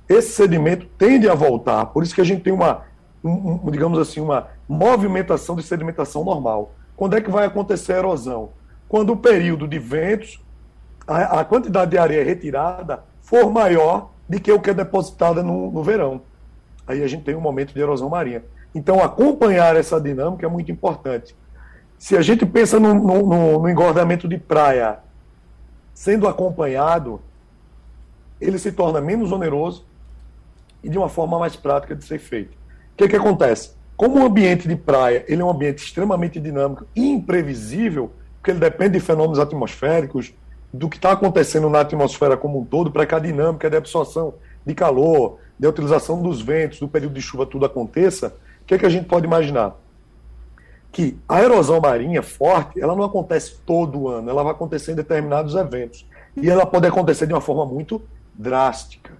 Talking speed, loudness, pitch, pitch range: 175 wpm, -18 LUFS, 160 Hz, 140-185 Hz